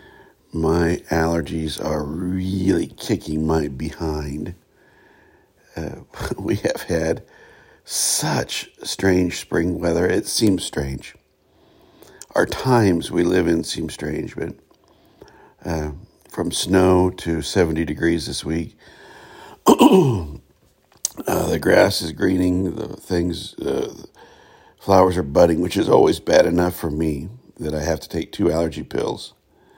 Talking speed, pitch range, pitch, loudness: 120 wpm, 80-90 Hz, 85 Hz, -20 LUFS